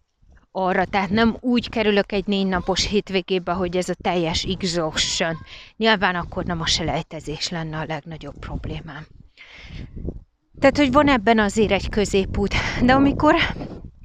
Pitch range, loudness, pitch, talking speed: 165-215 Hz, -21 LUFS, 190 Hz, 135 wpm